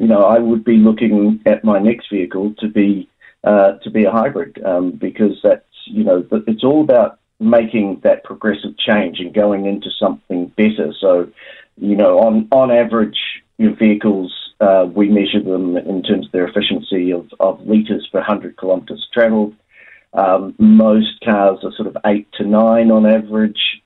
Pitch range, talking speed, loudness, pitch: 100-110 Hz, 175 wpm, -15 LUFS, 105 Hz